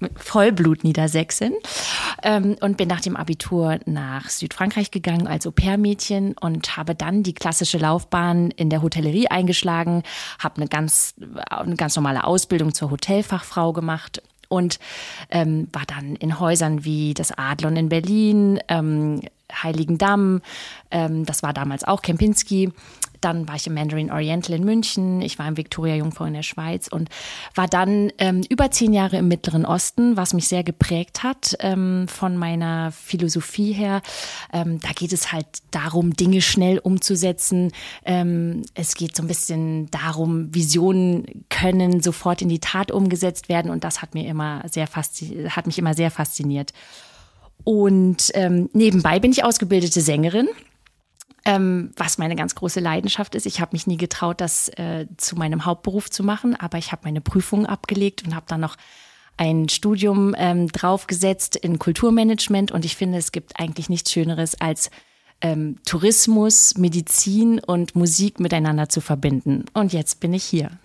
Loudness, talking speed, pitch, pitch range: -20 LUFS, 150 wpm, 175 Hz, 160-190 Hz